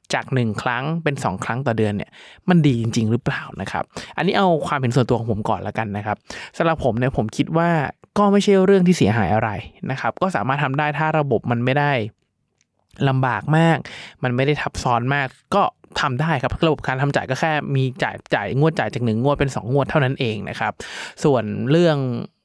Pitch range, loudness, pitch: 115-155 Hz, -20 LUFS, 135 Hz